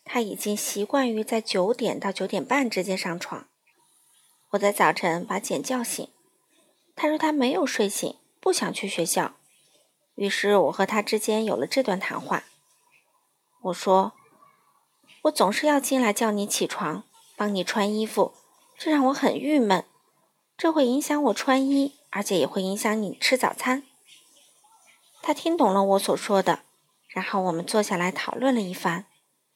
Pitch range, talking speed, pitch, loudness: 200-295 Hz, 225 characters per minute, 235 Hz, -25 LUFS